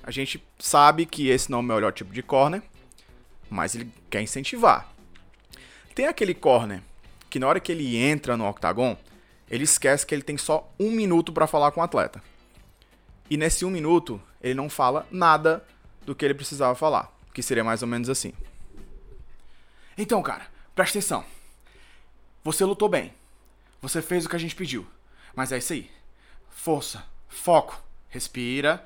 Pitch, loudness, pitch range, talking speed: 140 Hz, -24 LUFS, 120-165 Hz, 165 wpm